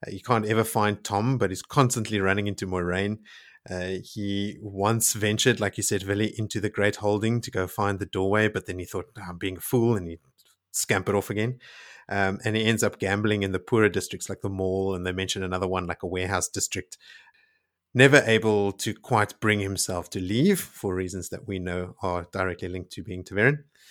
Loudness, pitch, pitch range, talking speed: -26 LUFS, 100 Hz, 95-110 Hz, 210 wpm